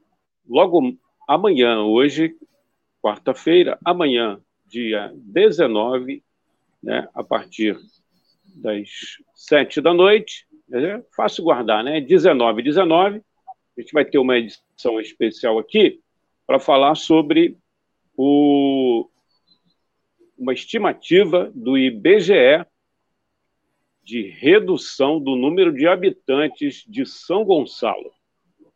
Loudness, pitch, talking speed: -18 LUFS, 190 Hz, 95 wpm